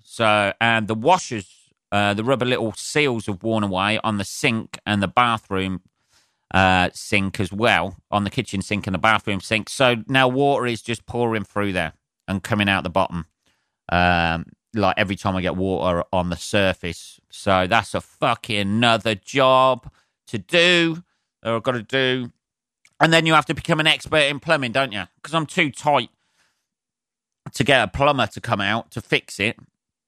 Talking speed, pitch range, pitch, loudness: 180 wpm, 95-130 Hz, 110 Hz, -20 LUFS